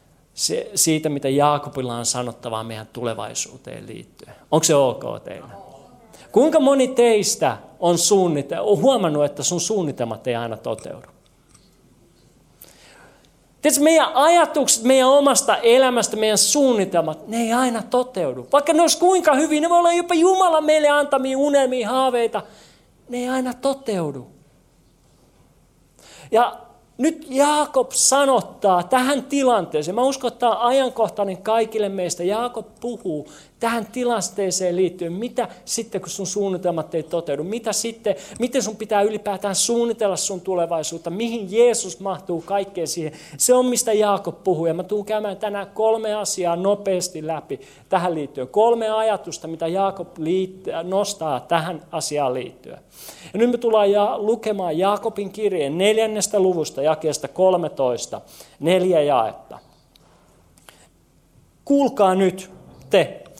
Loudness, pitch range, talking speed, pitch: -20 LUFS, 170-245 Hz, 130 wpm, 205 Hz